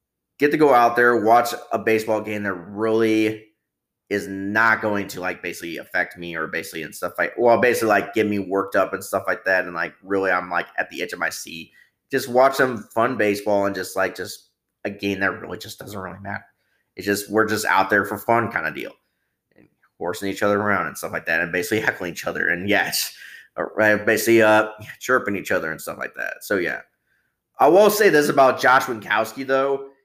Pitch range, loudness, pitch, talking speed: 95-110 Hz, -20 LUFS, 105 Hz, 220 wpm